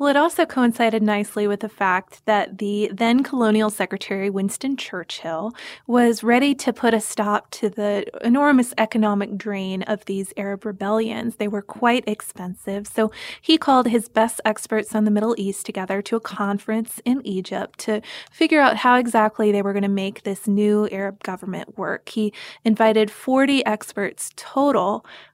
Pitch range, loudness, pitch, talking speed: 200-235 Hz, -21 LUFS, 215 Hz, 165 wpm